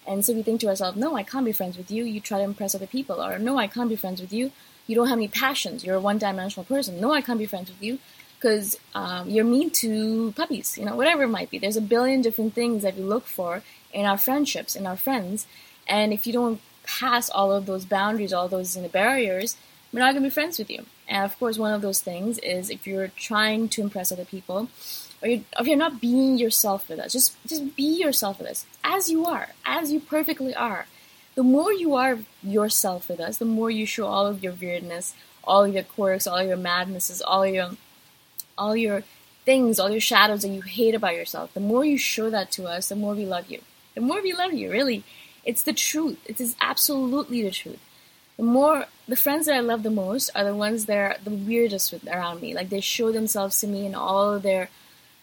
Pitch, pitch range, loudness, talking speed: 215 Hz, 195-255 Hz, -24 LUFS, 240 wpm